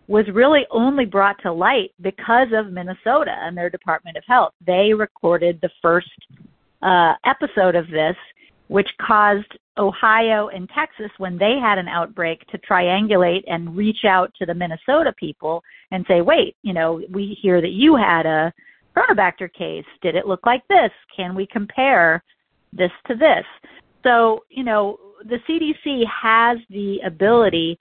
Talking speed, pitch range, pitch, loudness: 160 wpm, 180-230 Hz, 200 Hz, -18 LUFS